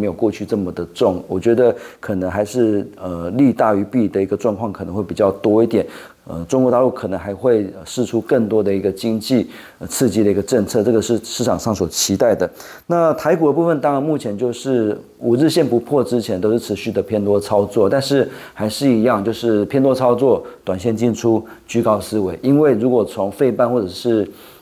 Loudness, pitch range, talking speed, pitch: -17 LUFS, 100-125 Hz, 310 characters per minute, 115 Hz